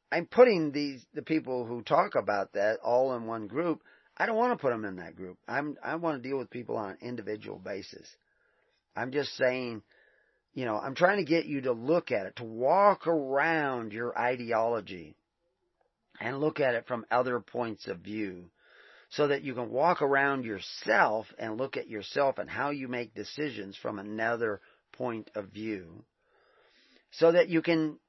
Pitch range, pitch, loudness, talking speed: 110-150 Hz, 125 Hz, -30 LUFS, 185 wpm